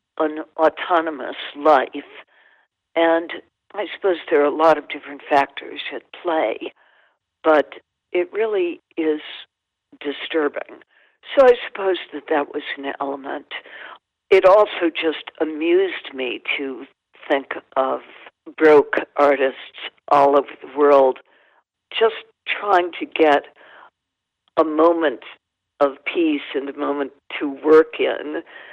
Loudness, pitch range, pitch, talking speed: -19 LUFS, 145-185 Hz, 155 Hz, 115 wpm